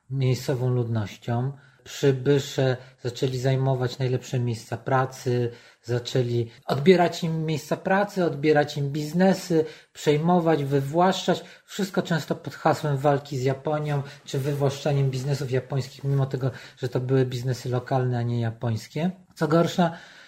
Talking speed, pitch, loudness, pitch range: 120 wpm, 140 Hz, -25 LUFS, 130-155 Hz